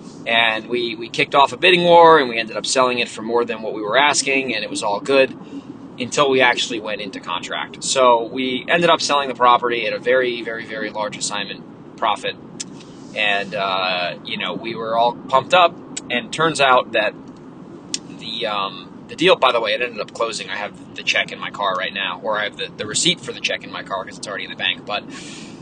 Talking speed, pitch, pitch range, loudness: 235 wpm, 125 Hz, 115-145 Hz, -18 LUFS